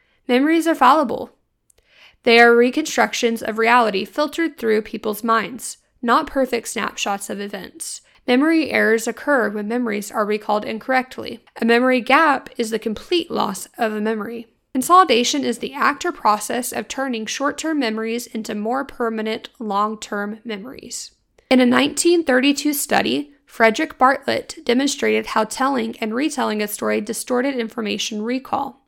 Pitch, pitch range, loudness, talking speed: 240 Hz, 220-275 Hz, -19 LUFS, 140 wpm